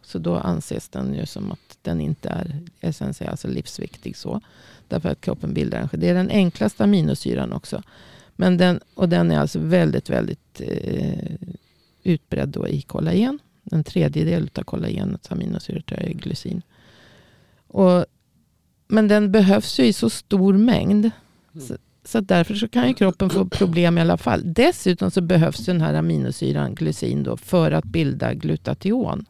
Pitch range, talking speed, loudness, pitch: 165-195 Hz, 160 wpm, -21 LUFS, 180 Hz